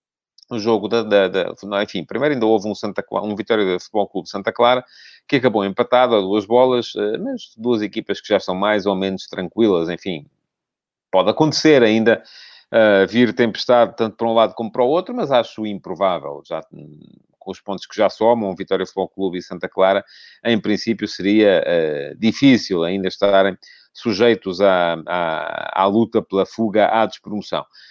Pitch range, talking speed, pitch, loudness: 95-115 Hz, 175 wpm, 105 Hz, -18 LUFS